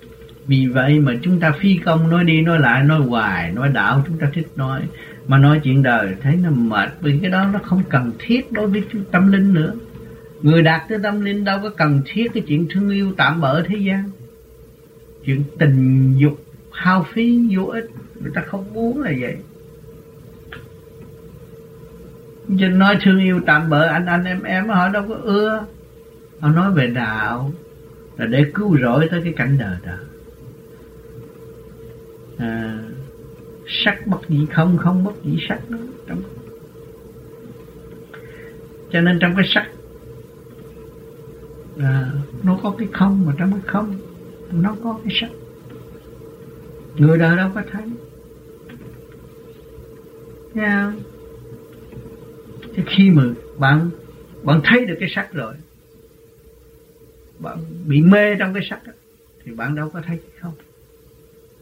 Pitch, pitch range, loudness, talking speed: 155 Hz, 140-190 Hz, -17 LUFS, 150 wpm